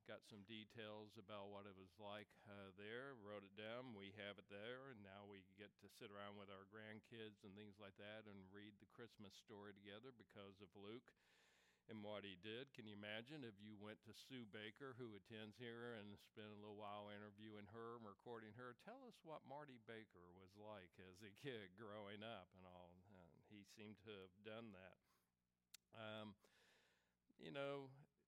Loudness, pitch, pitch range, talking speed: -59 LUFS, 105 Hz, 100-115 Hz, 190 wpm